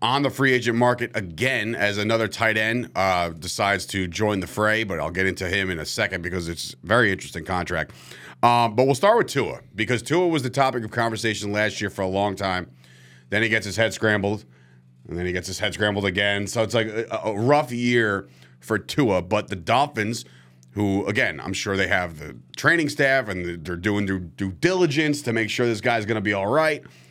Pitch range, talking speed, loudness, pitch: 90-120 Hz, 225 wpm, -23 LUFS, 105 Hz